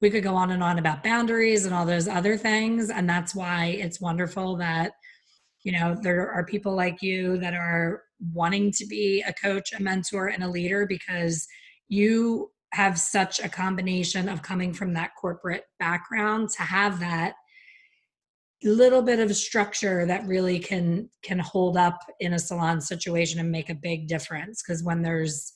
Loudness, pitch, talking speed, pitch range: -26 LUFS, 185 Hz, 175 wpm, 175-205 Hz